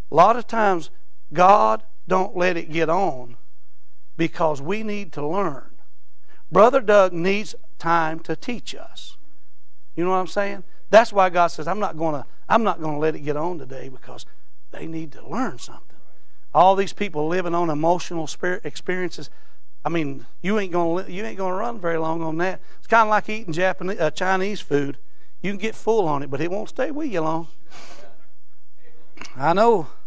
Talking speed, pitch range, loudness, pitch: 180 wpm, 150-195 Hz, -22 LUFS, 170 Hz